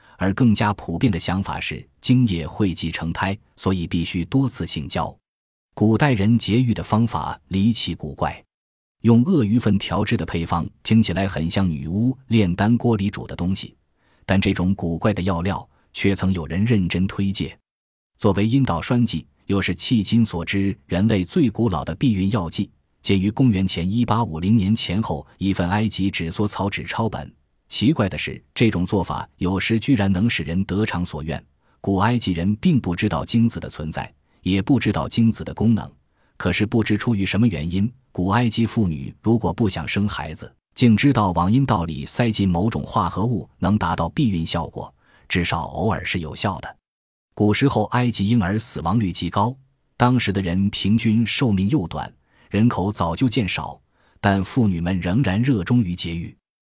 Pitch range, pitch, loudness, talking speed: 90-115 Hz, 100 Hz, -21 LUFS, 265 characters per minute